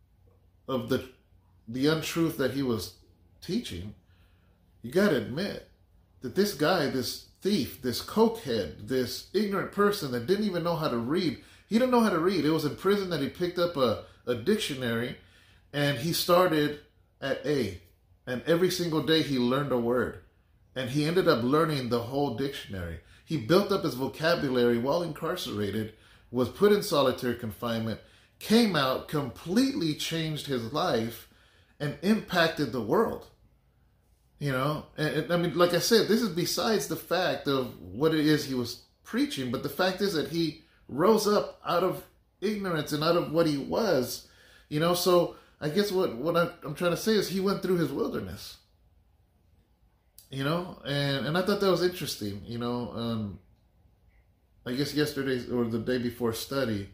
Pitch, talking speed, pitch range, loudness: 140 Hz, 170 wpm, 110-170 Hz, -28 LUFS